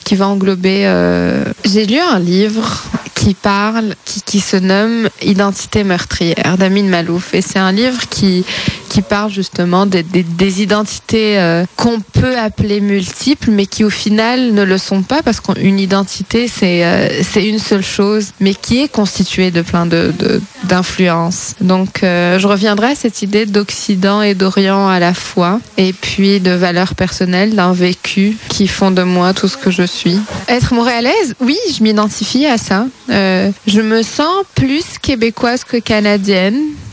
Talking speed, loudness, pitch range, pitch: 170 wpm, -12 LUFS, 185-220 Hz, 200 Hz